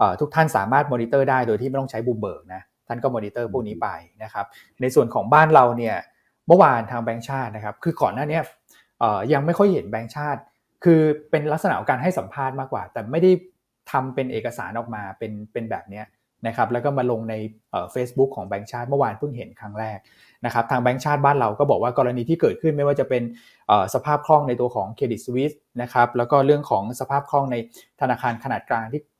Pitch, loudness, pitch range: 125 Hz, -22 LUFS, 115-145 Hz